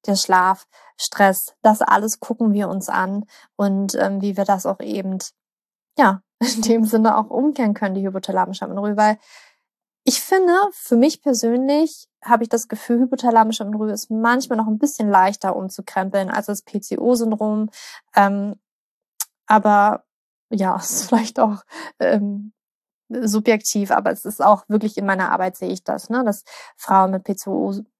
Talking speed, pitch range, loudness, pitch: 155 wpm, 200-235 Hz, -19 LUFS, 215 Hz